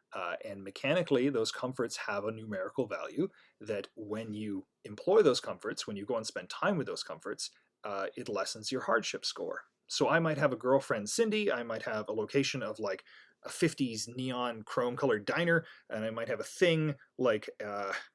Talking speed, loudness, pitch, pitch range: 190 wpm, -33 LUFS, 135 Hz, 110-170 Hz